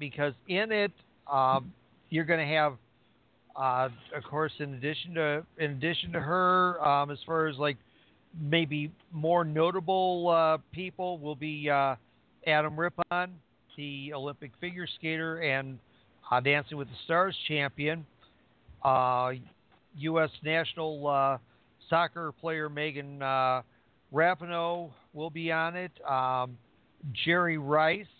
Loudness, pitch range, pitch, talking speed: -30 LUFS, 135-170 Hz, 150 Hz, 130 wpm